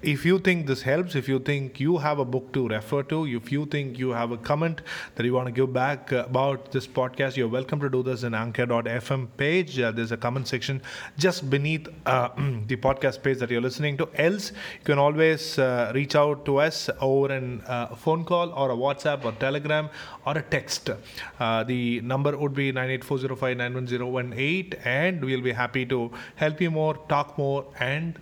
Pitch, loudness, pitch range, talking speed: 135 Hz, -26 LUFS, 125-150 Hz, 200 wpm